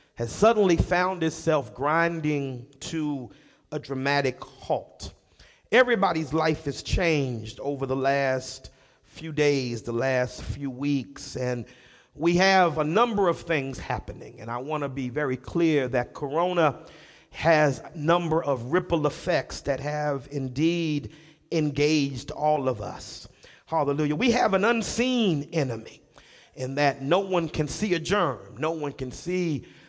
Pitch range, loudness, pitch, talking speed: 130-165 Hz, -26 LUFS, 150 Hz, 140 wpm